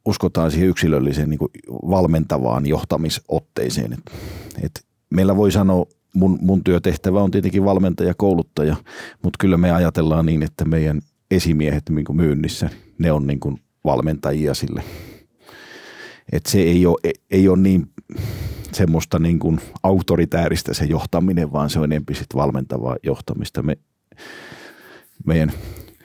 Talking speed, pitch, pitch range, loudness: 130 wpm, 85 Hz, 75-95 Hz, -19 LUFS